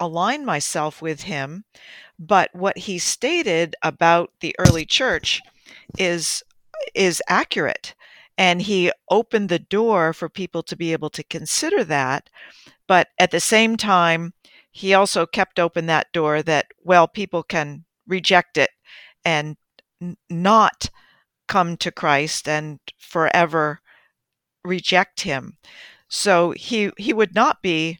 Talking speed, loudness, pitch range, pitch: 130 wpm, -20 LUFS, 165-195 Hz, 175 Hz